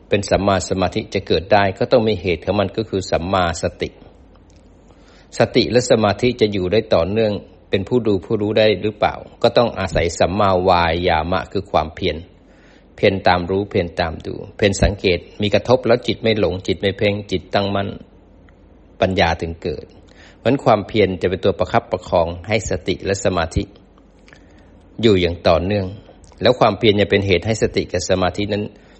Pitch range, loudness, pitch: 90-105 Hz, -18 LUFS, 100 Hz